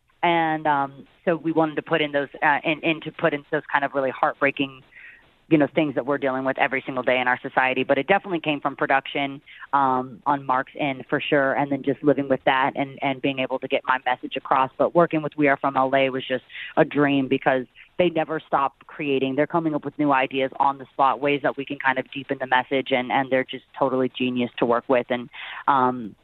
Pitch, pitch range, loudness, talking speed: 140 Hz, 130-150 Hz, -23 LUFS, 240 wpm